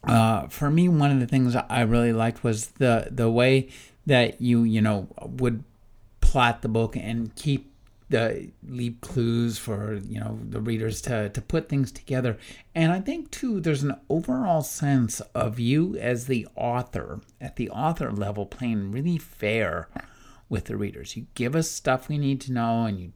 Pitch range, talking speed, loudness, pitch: 110-135 Hz, 180 wpm, -25 LUFS, 120 Hz